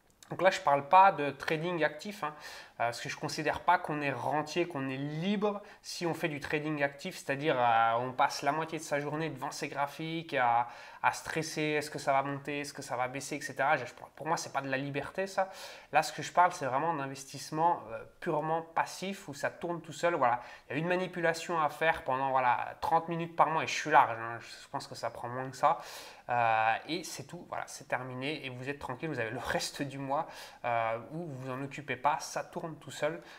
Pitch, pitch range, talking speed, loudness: 145 Hz, 135-165 Hz, 240 wpm, -32 LUFS